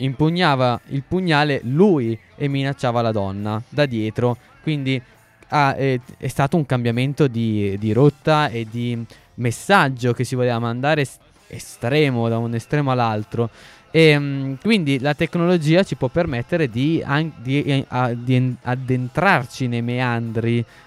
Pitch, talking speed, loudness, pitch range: 130 Hz, 130 wpm, -20 LUFS, 120-150 Hz